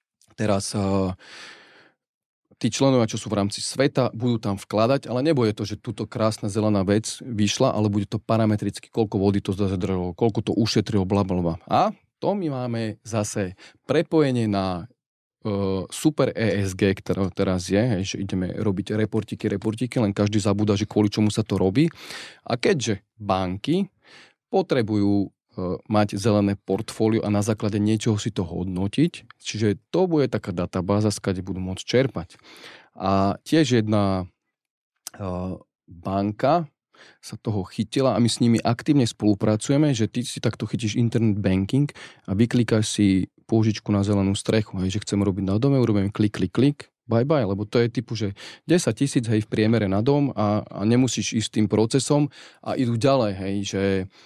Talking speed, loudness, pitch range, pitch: 165 wpm, -23 LUFS, 100-120 Hz, 105 Hz